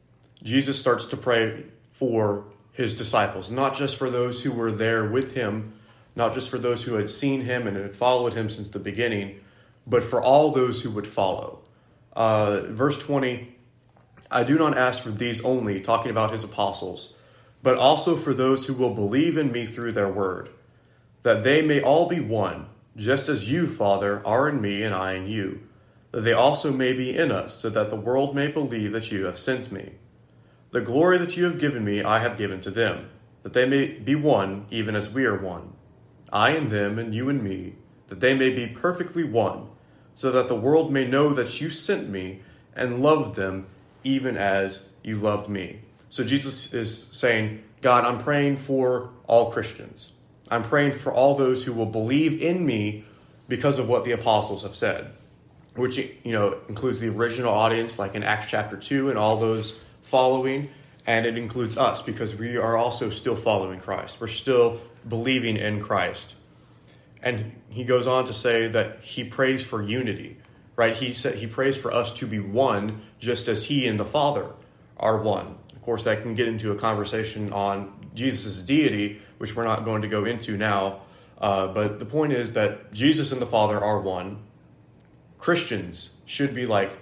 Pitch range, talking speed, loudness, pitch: 105-130 Hz, 190 wpm, -24 LUFS, 115 Hz